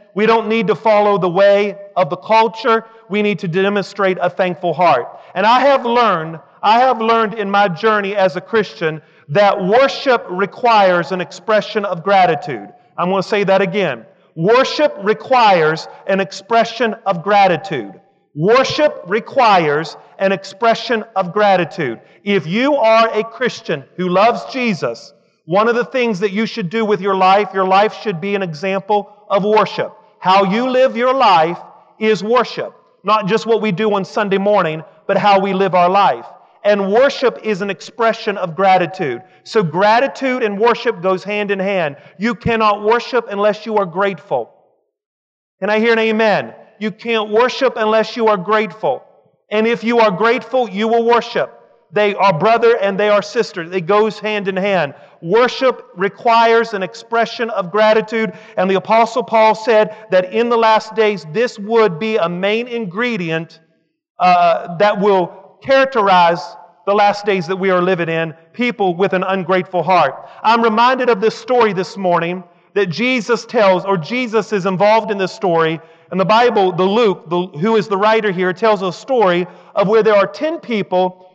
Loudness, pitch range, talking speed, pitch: -15 LUFS, 190-230 Hz, 170 wpm, 210 Hz